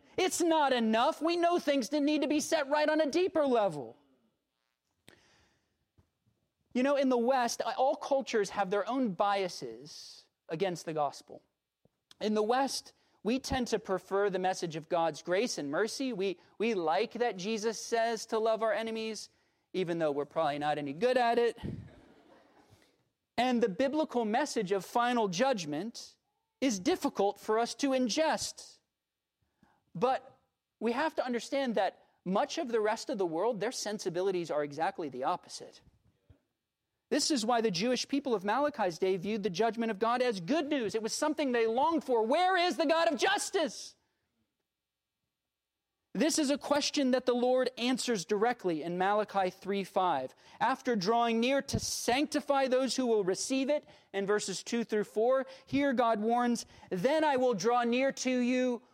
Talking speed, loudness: 165 wpm, -31 LUFS